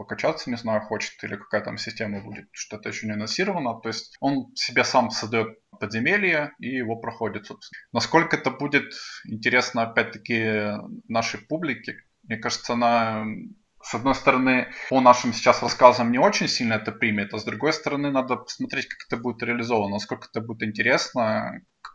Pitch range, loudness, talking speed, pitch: 110-130 Hz, -24 LUFS, 165 wpm, 120 Hz